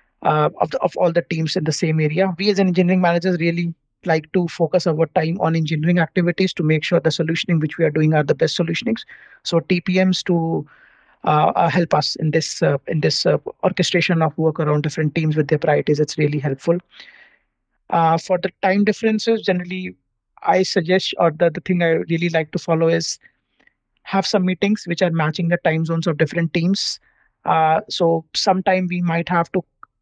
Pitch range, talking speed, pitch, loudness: 160-185 Hz, 200 wpm, 170 Hz, -19 LUFS